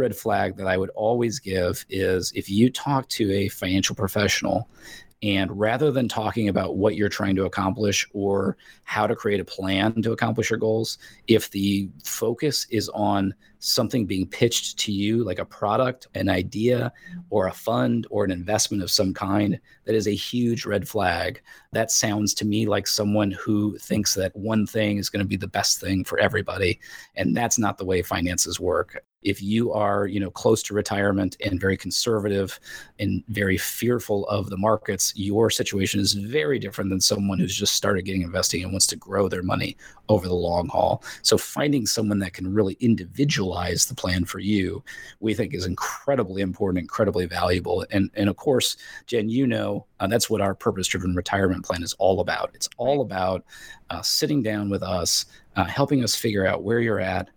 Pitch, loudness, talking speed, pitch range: 100 Hz, -24 LUFS, 190 wpm, 95-110 Hz